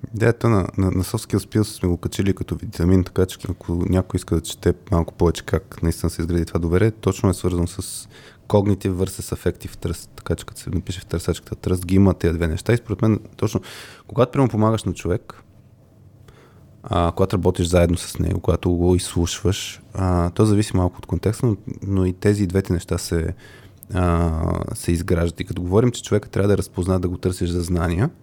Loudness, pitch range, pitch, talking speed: -21 LUFS, 90-110 Hz, 95 Hz, 200 wpm